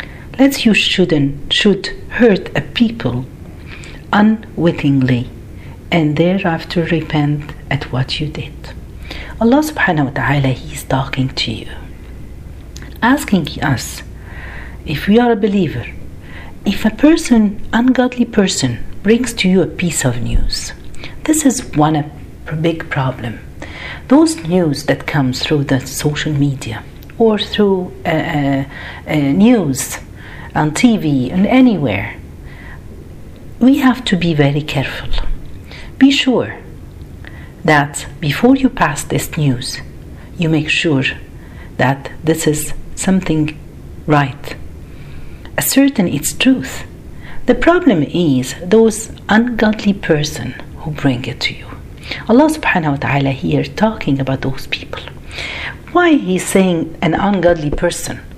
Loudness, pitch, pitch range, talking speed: -15 LUFS, 155 Hz, 135-210 Hz, 120 wpm